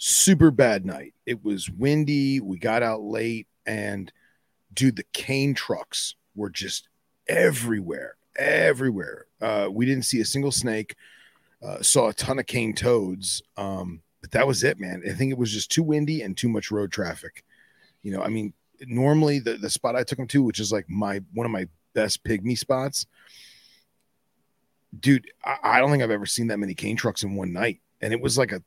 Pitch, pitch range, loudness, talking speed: 110 Hz, 100-135 Hz, -24 LUFS, 195 wpm